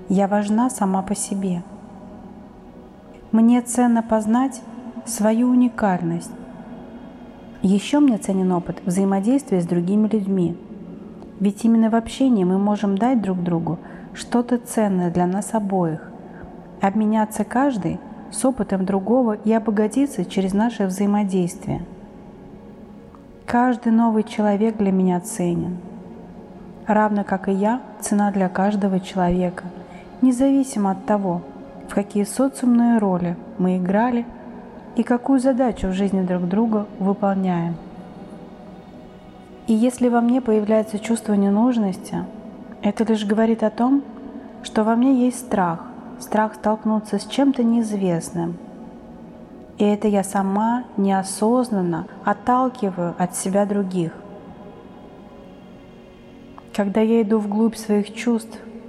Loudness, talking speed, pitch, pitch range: -20 LUFS, 110 wpm, 210 Hz, 195-230 Hz